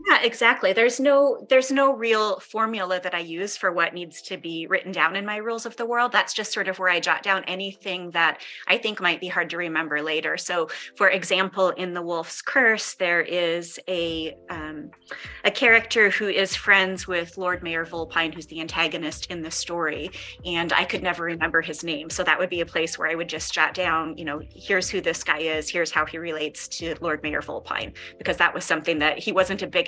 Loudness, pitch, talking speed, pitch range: -23 LUFS, 175 Hz, 225 wpm, 165-195 Hz